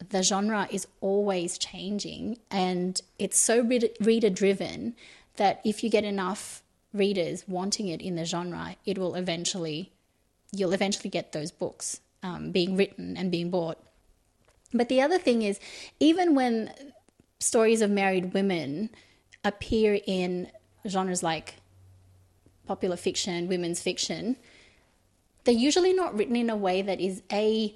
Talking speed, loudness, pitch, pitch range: 135 wpm, -28 LUFS, 195 Hz, 175-220 Hz